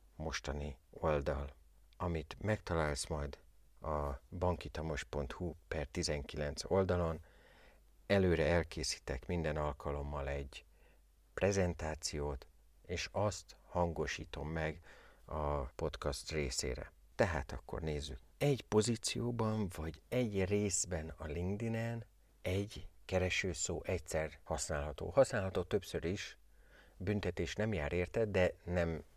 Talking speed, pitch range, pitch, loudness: 95 wpm, 75-95 Hz, 80 Hz, -38 LUFS